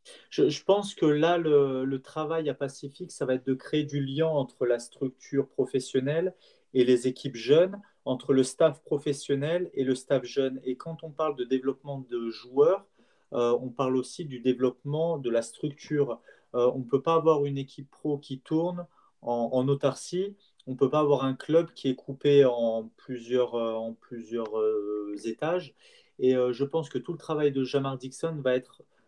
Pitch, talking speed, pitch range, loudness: 140 Hz, 190 wpm, 130-155 Hz, -28 LUFS